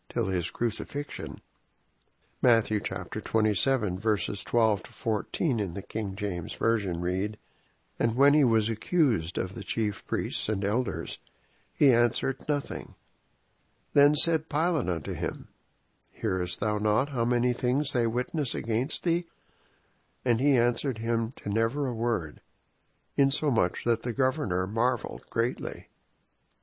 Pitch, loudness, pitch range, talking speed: 115 Hz, -28 LUFS, 105-135 Hz, 135 wpm